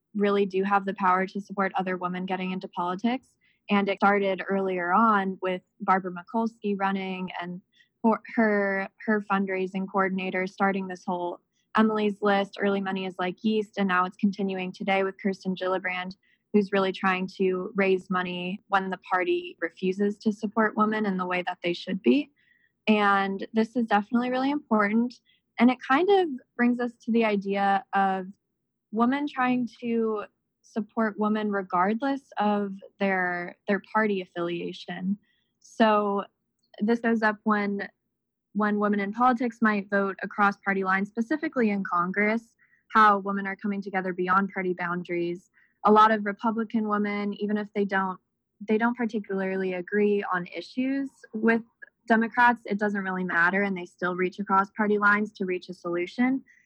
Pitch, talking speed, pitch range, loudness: 200 Hz, 160 wpm, 185-220 Hz, -26 LUFS